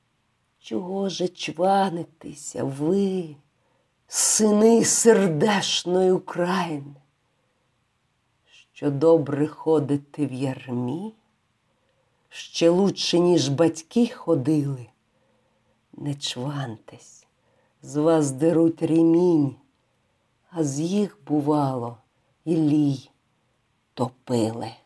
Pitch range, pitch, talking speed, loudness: 130-170 Hz, 150 Hz, 70 wpm, -22 LUFS